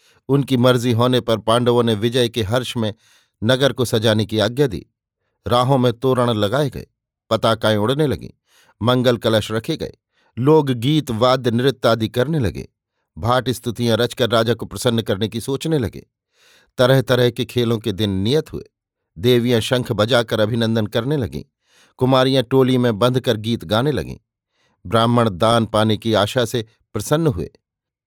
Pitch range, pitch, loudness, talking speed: 110-125 Hz, 120 Hz, -18 LUFS, 160 wpm